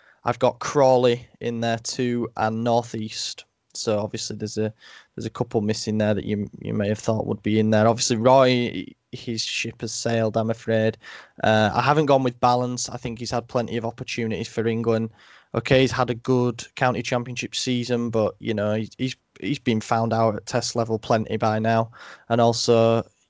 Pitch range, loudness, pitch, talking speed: 110-125 Hz, -23 LUFS, 115 Hz, 190 wpm